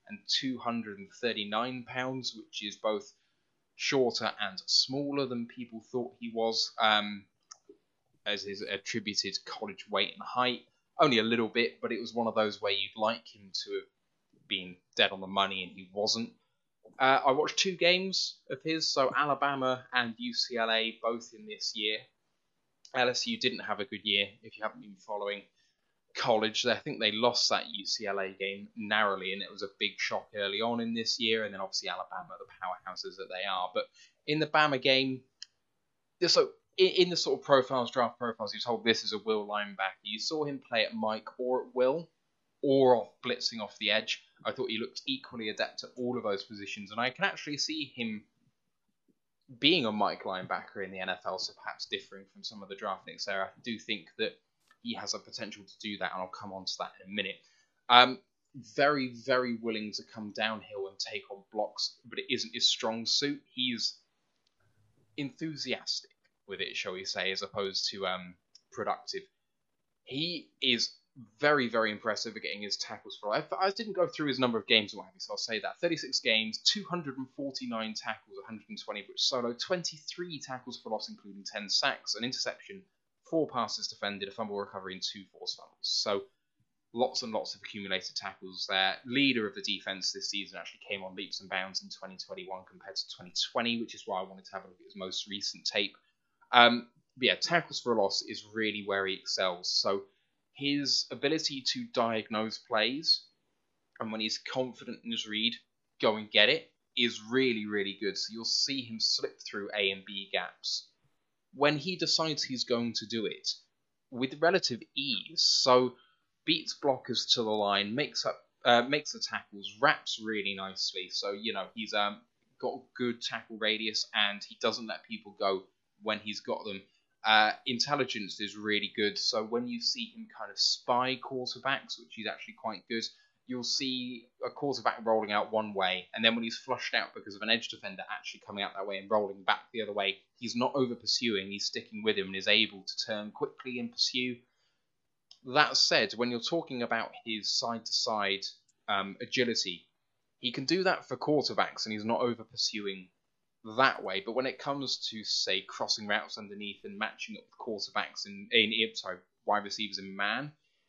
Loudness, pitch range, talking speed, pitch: -31 LUFS, 105-135 Hz, 190 wpm, 115 Hz